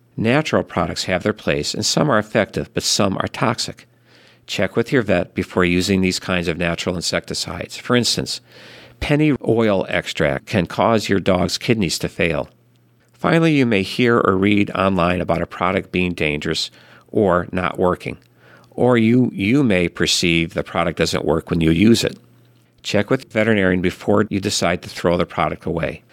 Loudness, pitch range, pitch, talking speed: -19 LUFS, 90-115 Hz, 95 Hz, 175 wpm